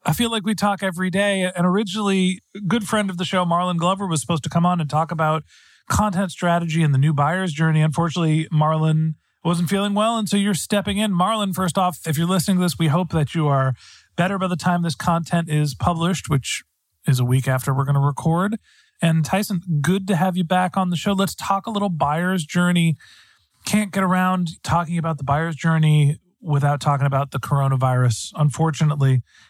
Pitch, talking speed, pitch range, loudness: 170 Hz, 210 wpm, 155-190 Hz, -20 LUFS